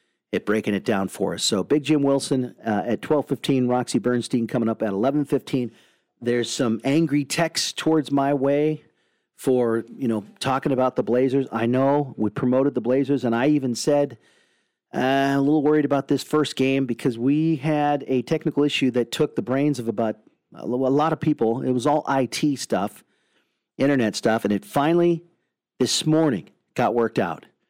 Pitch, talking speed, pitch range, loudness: 135 Hz, 180 wpm, 120-145 Hz, -22 LUFS